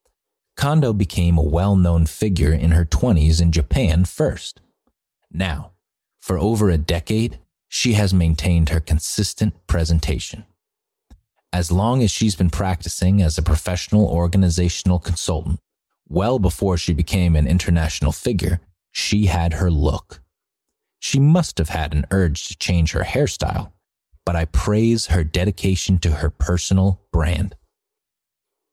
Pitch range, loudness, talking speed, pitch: 85-100 Hz, -19 LUFS, 135 wpm, 90 Hz